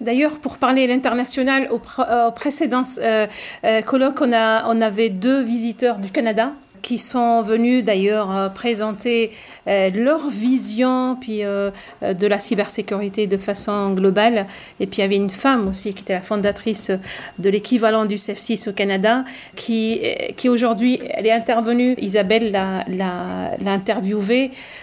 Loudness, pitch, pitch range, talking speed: -18 LUFS, 225 Hz, 205-250 Hz, 155 wpm